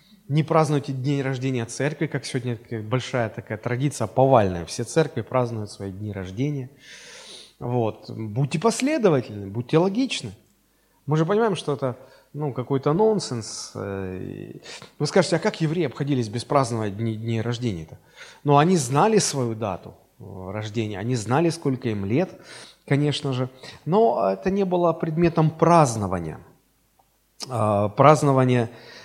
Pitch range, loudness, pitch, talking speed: 115-155 Hz, -23 LUFS, 130 Hz, 125 wpm